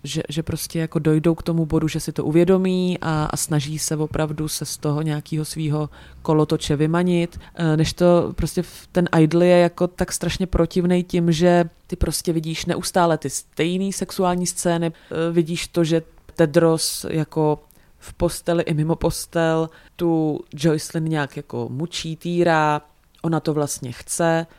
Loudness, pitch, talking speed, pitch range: -21 LUFS, 165 Hz, 155 wpm, 155-175 Hz